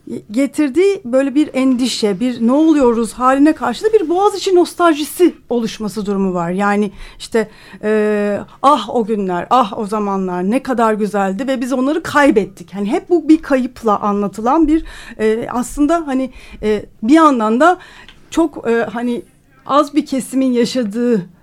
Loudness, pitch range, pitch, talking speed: -15 LUFS, 215-295 Hz, 245 Hz, 150 wpm